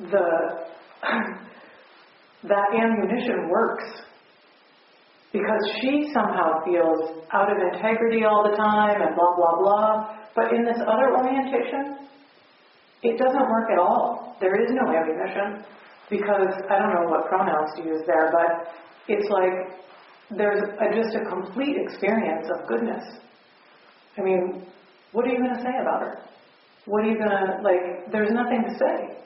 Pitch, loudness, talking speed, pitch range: 205 Hz, -23 LUFS, 150 wpm, 185-230 Hz